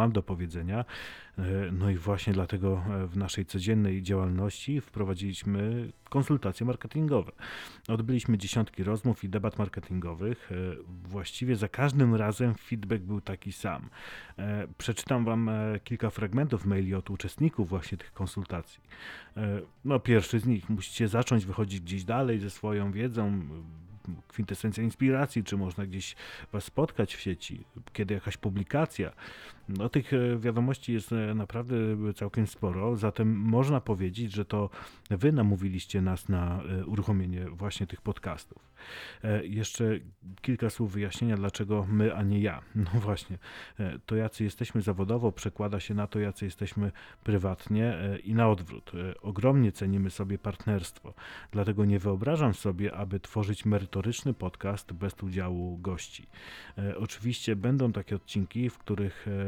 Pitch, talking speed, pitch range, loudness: 105 Hz, 130 wpm, 95-115 Hz, -31 LUFS